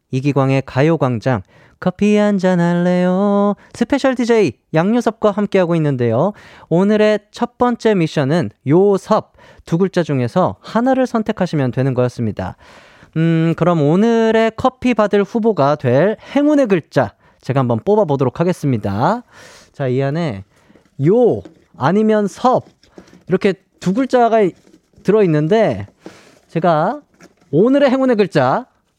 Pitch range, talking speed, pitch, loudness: 145-215 Hz, 265 characters per minute, 185 Hz, -16 LUFS